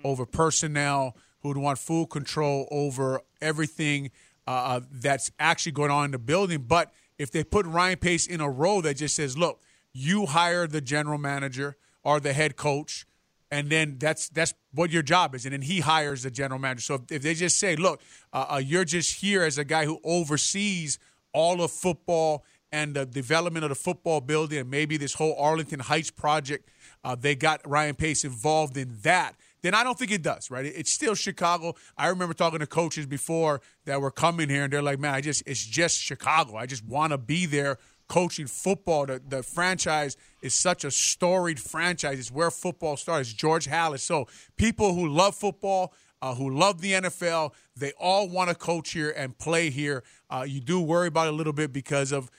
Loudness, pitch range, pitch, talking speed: -26 LUFS, 140-170 Hz, 155 Hz, 200 wpm